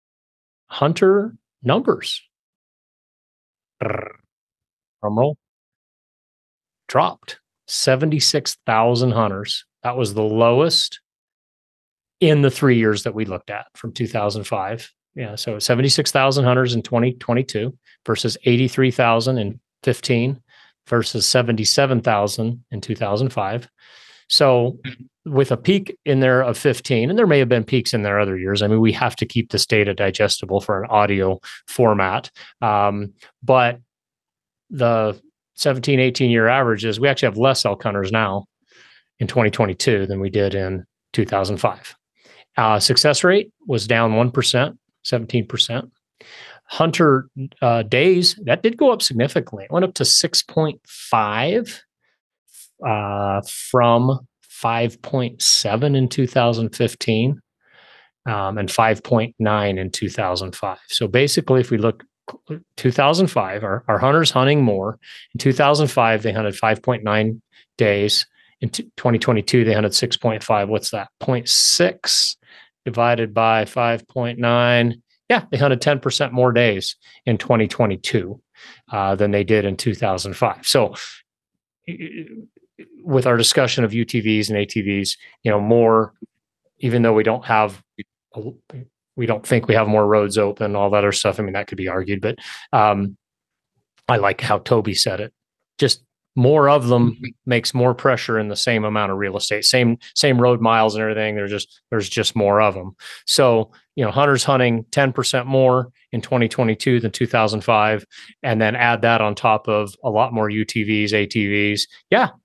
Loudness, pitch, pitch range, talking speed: -18 LUFS, 115 Hz, 105-130 Hz, 145 wpm